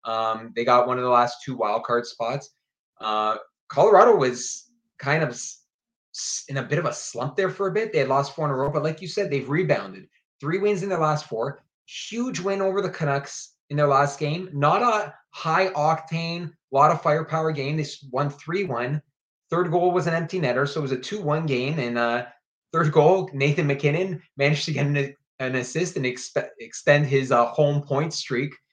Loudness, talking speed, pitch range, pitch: -23 LUFS, 205 wpm, 130-170 Hz, 145 Hz